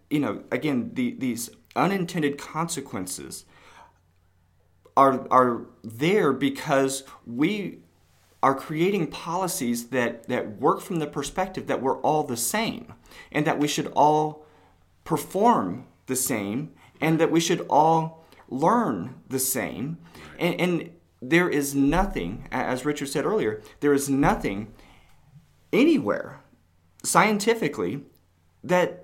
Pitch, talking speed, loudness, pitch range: 140 Hz, 120 wpm, -25 LUFS, 115-165 Hz